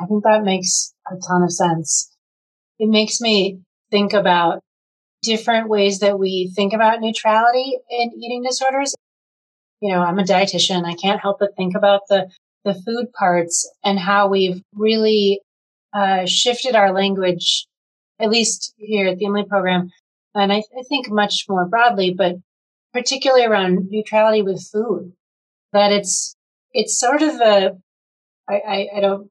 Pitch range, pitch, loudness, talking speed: 185-220 Hz, 200 Hz, -18 LUFS, 160 wpm